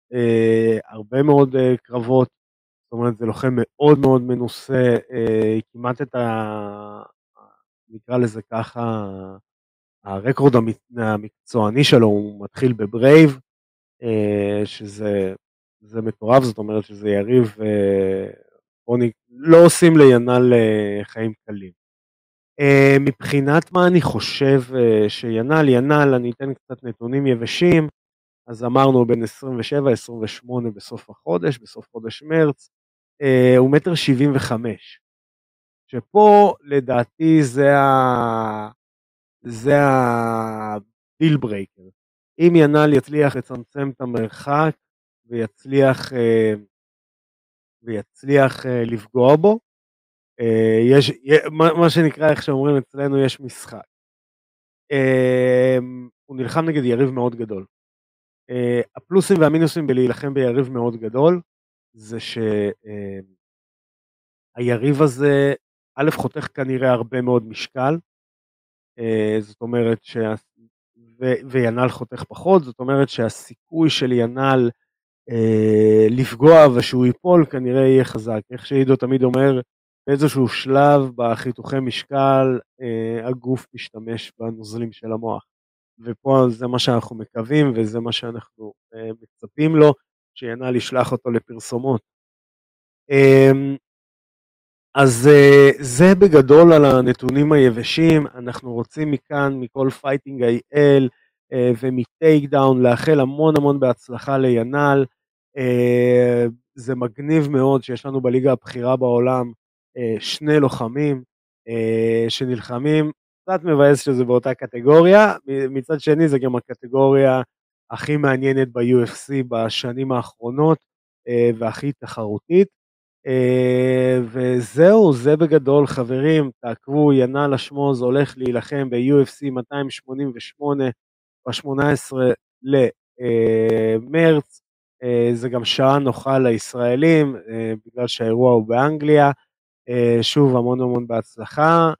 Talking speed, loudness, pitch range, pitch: 105 wpm, -17 LUFS, 115-140 Hz, 125 Hz